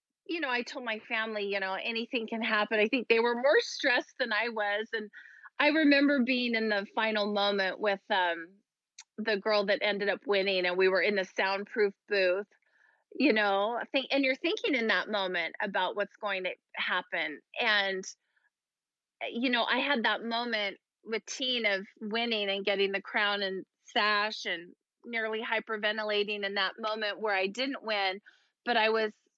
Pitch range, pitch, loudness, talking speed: 200-235 Hz, 210 Hz, -30 LUFS, 180 wpm